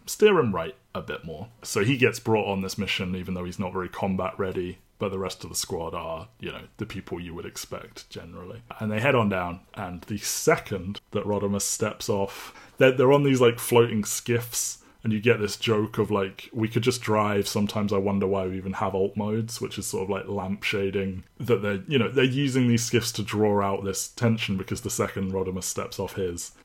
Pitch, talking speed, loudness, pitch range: 100 Hz, 225 wpm, -26 LUFS, 95-115 Hz